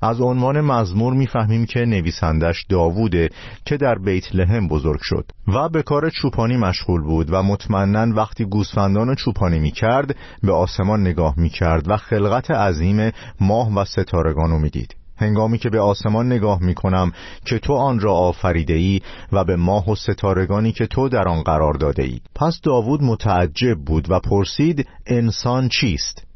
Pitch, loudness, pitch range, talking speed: 100 Hz, -19 LUFS, 90-115 Hz, 165 wpm